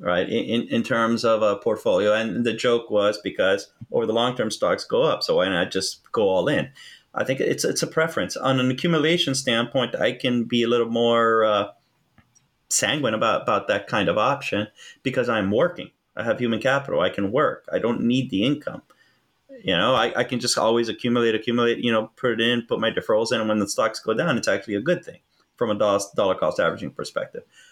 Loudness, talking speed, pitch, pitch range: -22 LUFS, 220 wpm, 120 Hz, 115-160 Hz